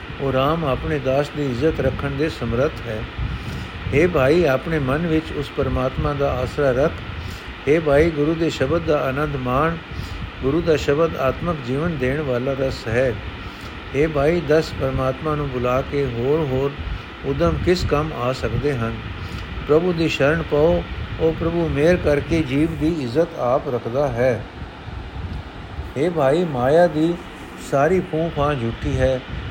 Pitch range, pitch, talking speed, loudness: 120-155 Hz, 140 Hz, 150 wpm, -21 LUFS